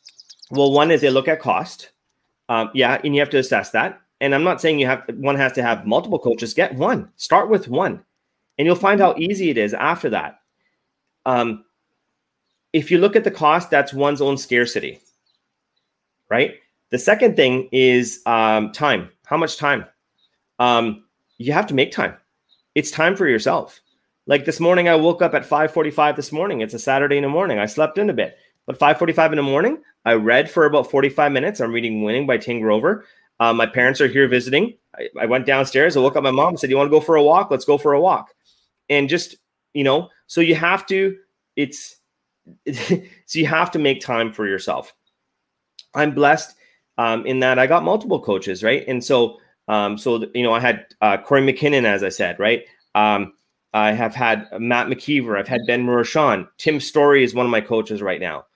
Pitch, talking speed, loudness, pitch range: 135 Hz, 205 wpm, -18 LUFS, 120-155 Hz